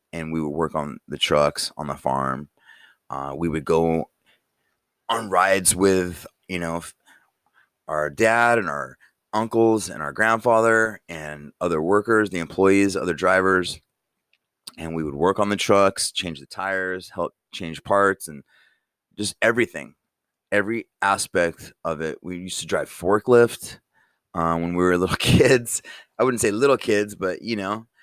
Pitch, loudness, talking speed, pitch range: 95 Hz, -22 LUFS, 155 wpm, 85-105 Hz